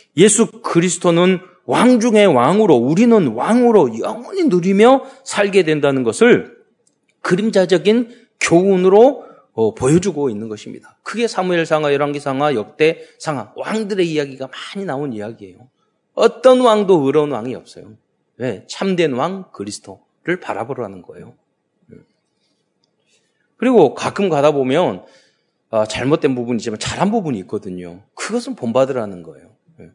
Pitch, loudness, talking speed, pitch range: 180 Hz, -16 LUFS, 305 characters per minute, 135-220 Hz